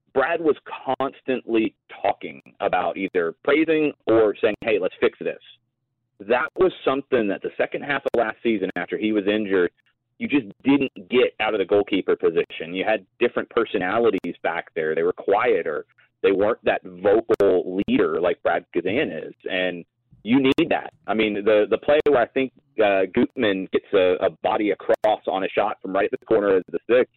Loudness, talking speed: -22 LUFS, 185 wpm